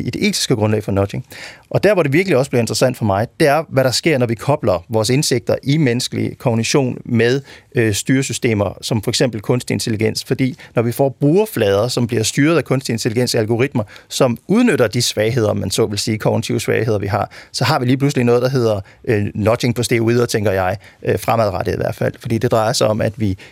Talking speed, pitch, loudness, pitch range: 225 wpm, 120 Hz, -17 LUFS, 110-130 Hz